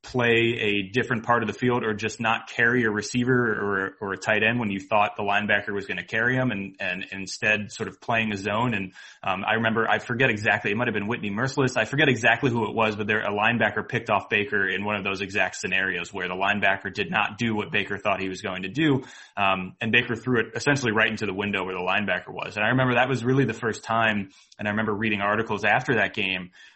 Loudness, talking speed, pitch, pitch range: -24 LUFS, 255 wpm, 110 Hz, 100-120 Hz